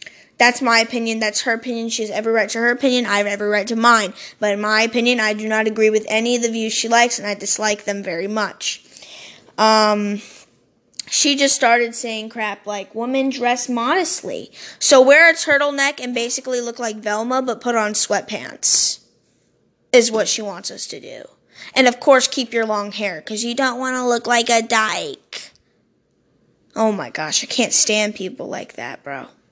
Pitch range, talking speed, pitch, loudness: 215-245 Hz, 190 wpm, 230 Hz, -17 LUFS